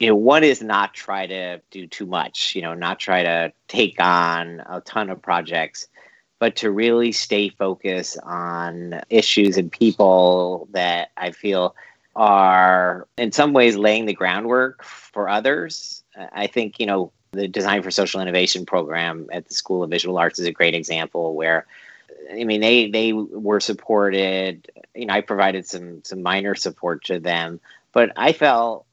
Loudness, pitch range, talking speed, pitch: -19 LUFS, 85-105 Hz, 170 wpm, 95 Hz